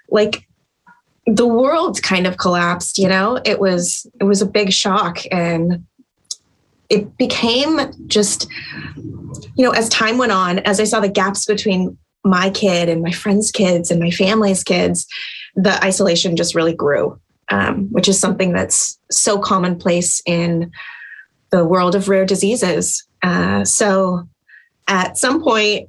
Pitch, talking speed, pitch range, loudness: 190 Hz, 150 wpm, 175-215 Hz, -16 LUFS